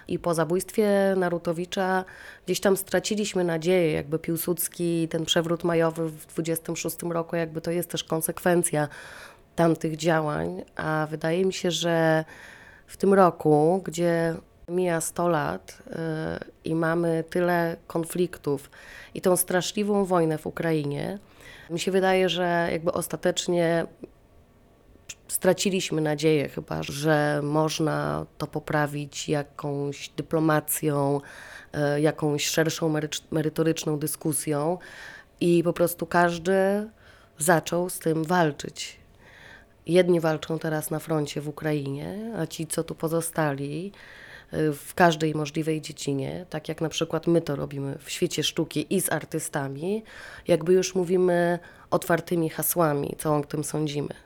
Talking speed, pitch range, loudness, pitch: 120 wpm, 155-175 Hz, -26 LUFS, 165 Hz